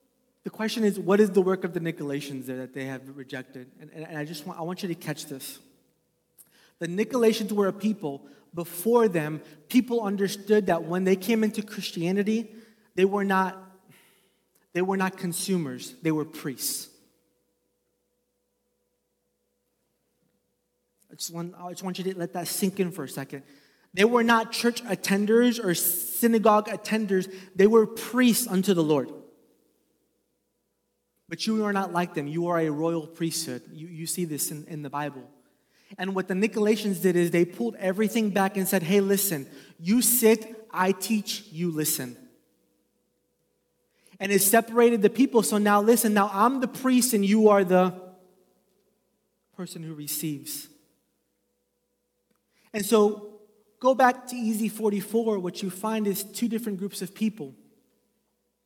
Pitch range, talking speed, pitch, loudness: 160-215 Hz, 160 wpm, 190 Hz, -25 LUFS